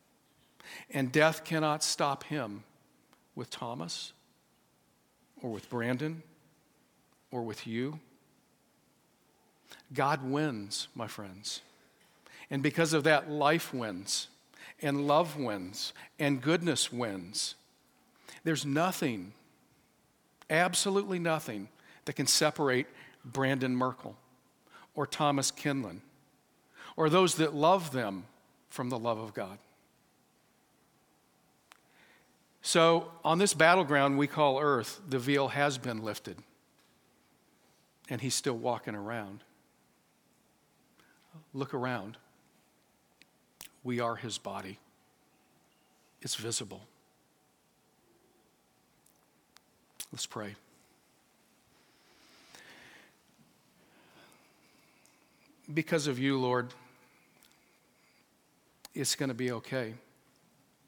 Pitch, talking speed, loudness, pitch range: 140 Hz, 85 wpm, -31 LUFS, 125-155 Hz